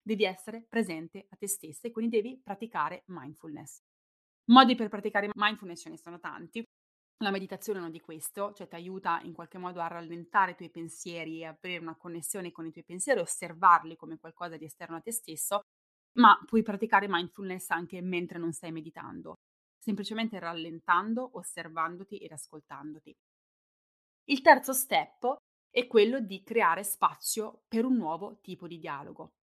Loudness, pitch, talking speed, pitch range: -29 LUFS, 180 Hz, 160 wpm, 165-215 Hz